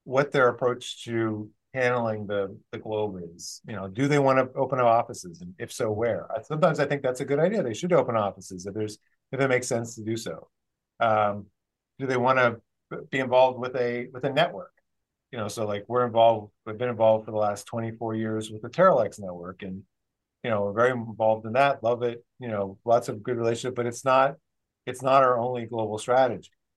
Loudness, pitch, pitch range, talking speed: -26 LUFS, 115 Hz, 105-125 Hz, 215 wpm